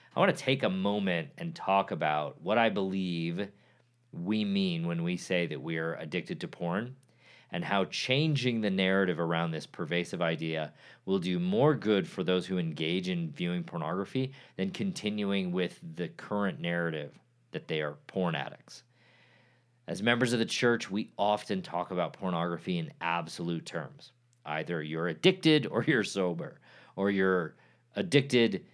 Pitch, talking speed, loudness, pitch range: 105 Hz, 160 wpm, -31 LUFS, 85-130 Hz